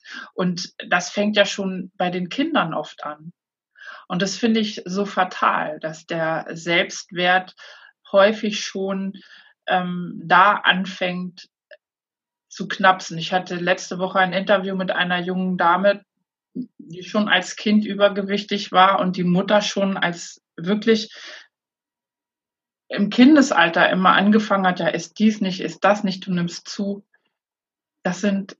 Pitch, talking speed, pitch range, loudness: 195 Hz, 135 wpm, 180-205 Hz, -20 LUFS